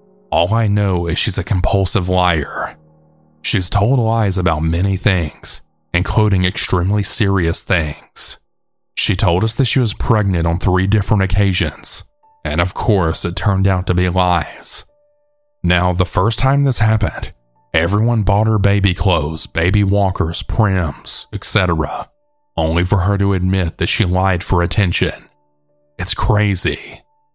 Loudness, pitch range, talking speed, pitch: -16 LUFS, 85-105 Hz, 145 wpm, 95 Hz